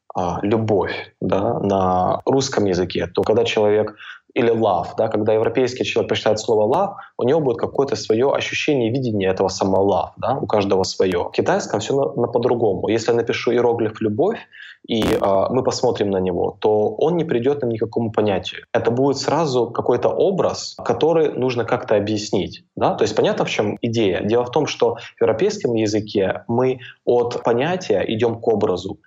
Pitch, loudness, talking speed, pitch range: 115 Hz, -19 LUFS, 175 wpm, 105-125 Hz